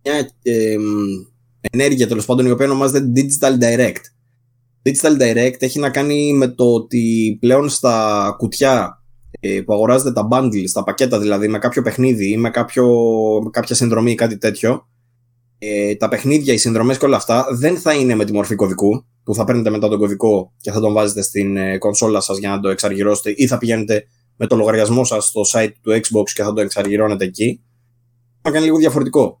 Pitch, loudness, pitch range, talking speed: 115 Hz, -16 LUFS, 105-125 Hz, 190 wpm